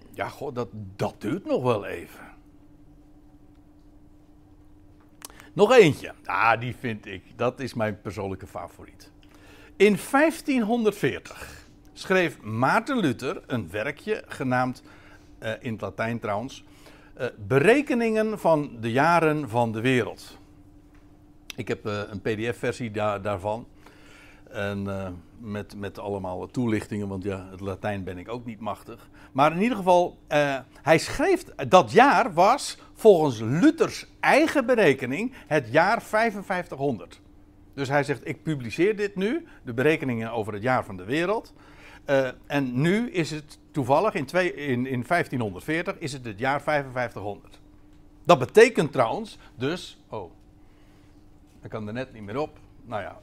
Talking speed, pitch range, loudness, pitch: 140 wpm, 100-150 Hz, -25 LUFS, 120 Hz